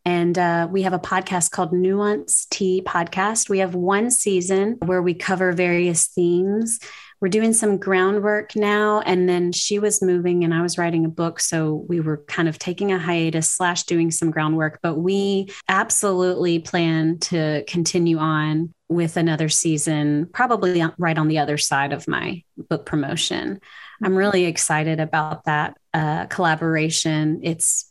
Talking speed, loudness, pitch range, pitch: 160 wpm, -20 LUFS, 160-190 Hz, 175 Hz